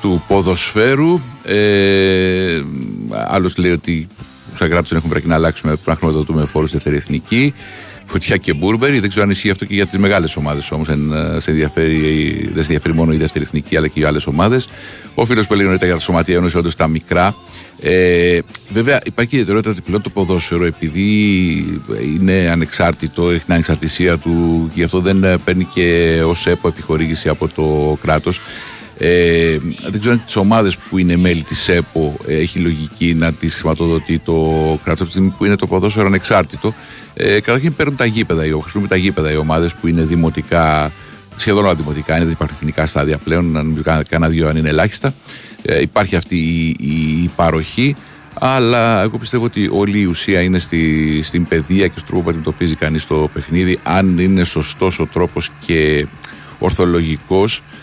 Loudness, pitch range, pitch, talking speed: -15 LUFS, 80-95 Hz, 85 Hz, 180 wpm